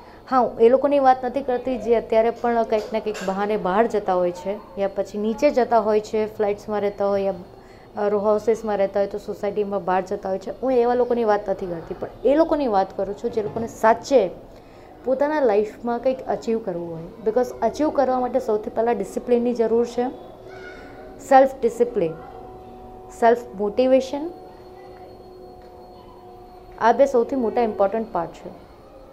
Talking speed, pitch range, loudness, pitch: 160 wpm, 200-245 Hz, -22 LUFS, 220 Hz